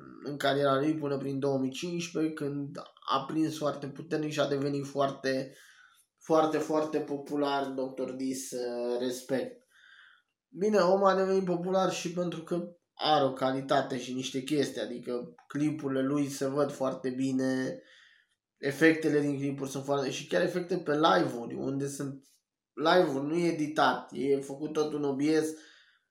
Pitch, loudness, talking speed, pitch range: 140 Hz, -30 LUFS, 145 wpm, 135-155 Hz